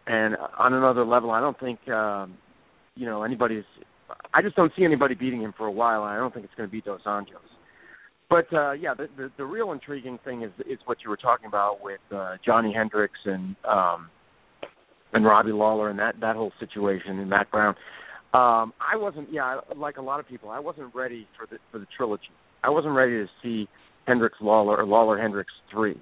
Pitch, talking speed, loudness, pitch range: 115 Hz, 210 wpm, -25 LUFS, 105-130 Hz